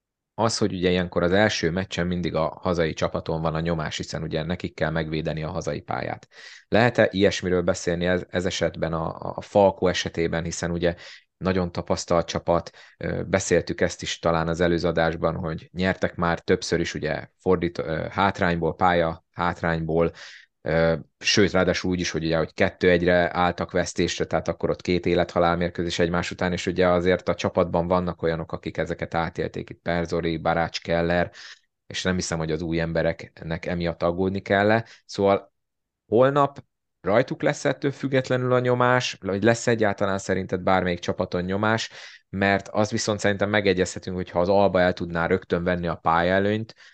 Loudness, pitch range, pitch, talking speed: -24 LUFS, 85-95 Hz, 90 Hz, 165 wpm